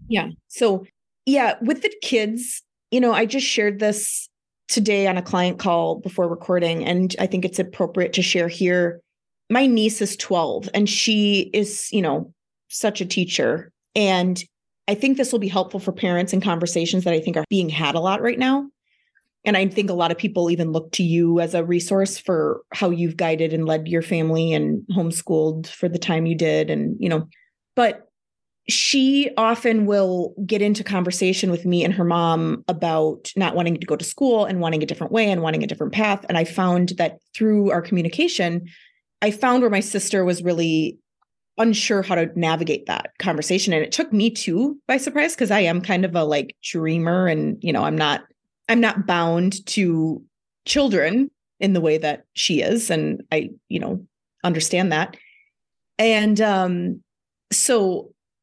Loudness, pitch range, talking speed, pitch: -21 LUFS, 170-215 Hz, 185 wpm, 185 Hz